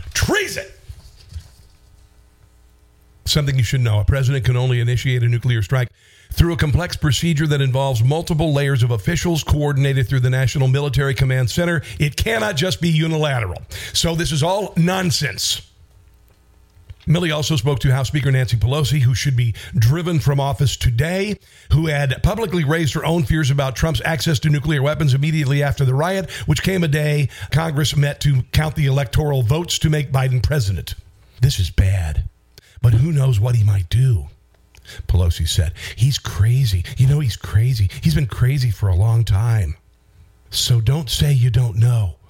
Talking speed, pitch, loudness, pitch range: 165 wpm, 130 Hz, -18 LUFS, 105-150 Hz